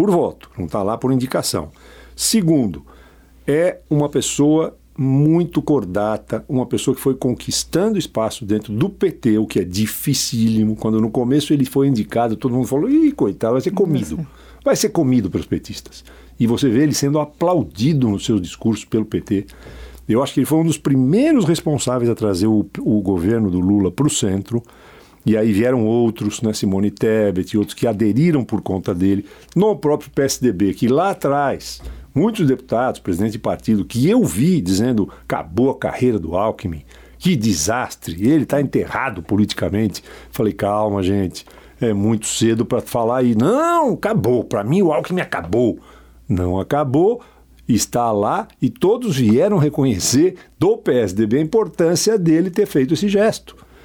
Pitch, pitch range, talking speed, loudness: 120 Hz, 105-145 Hz, 165 wpm, -18 LUFS